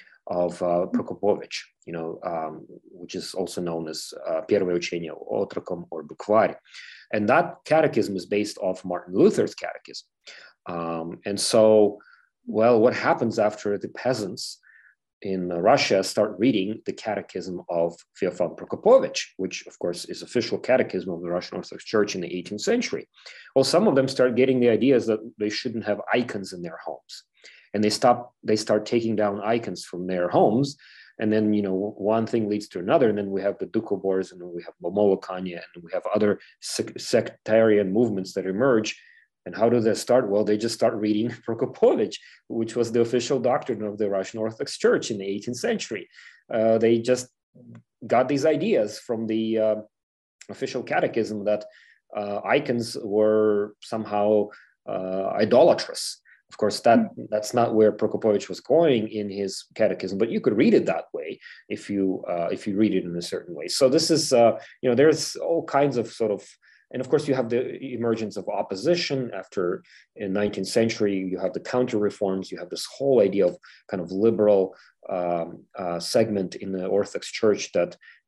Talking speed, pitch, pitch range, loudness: 175 wpm, 105 Hz, 95-115 Hz, -24 LUFS